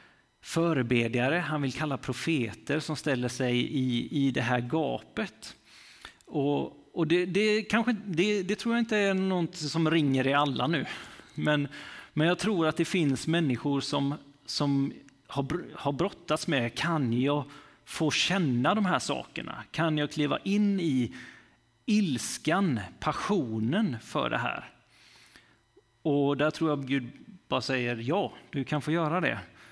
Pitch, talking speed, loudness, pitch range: 150 Hz, 150 wpm, -29 LUFS, 135-170 Hz